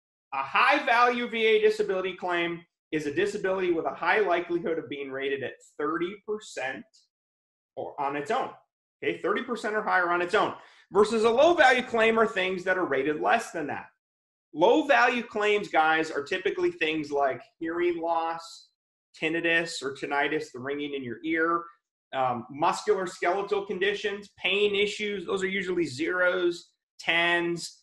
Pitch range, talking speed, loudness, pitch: 165-210 Hz, 155 wpm, -26 LUFS, 180 Hz